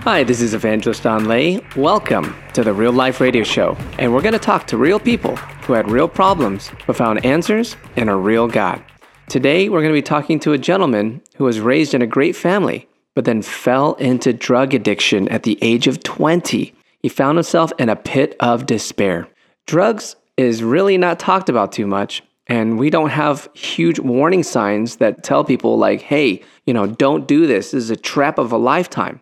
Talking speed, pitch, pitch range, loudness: 205 wpm, 130 Hz, 115-160 Hz, -16 LUFS